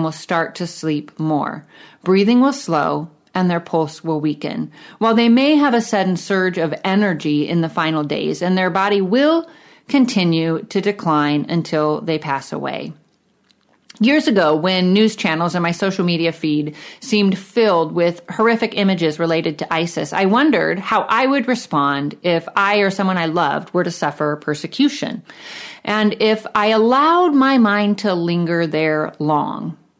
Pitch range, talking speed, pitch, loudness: 160-215 Hz, 160 wpm, 180 Hz, -17 LUFS